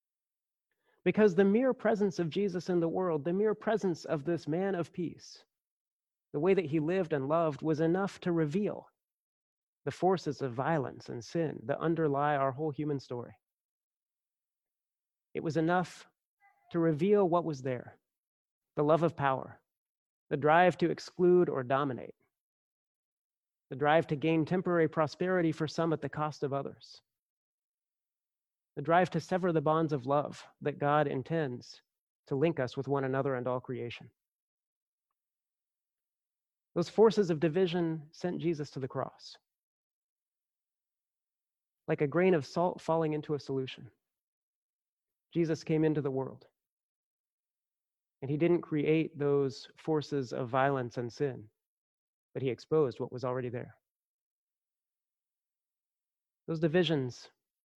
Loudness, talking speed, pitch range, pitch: -31 LUFS, 140 wpm, 140-175 Hz, 155 Hz